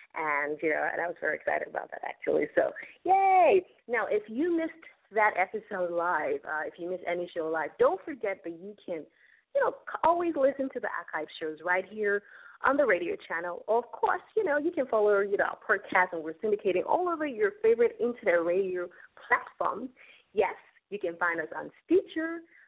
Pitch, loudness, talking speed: 215 Hz, -29 LUFS, 195 wpm